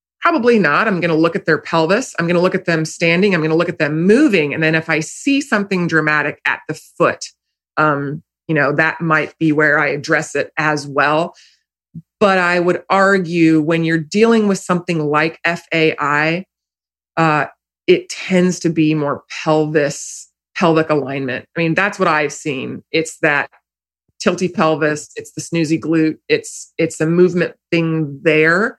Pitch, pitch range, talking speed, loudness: 160 Hz, 155-180 Hz, 175 wpm, -16 LUFS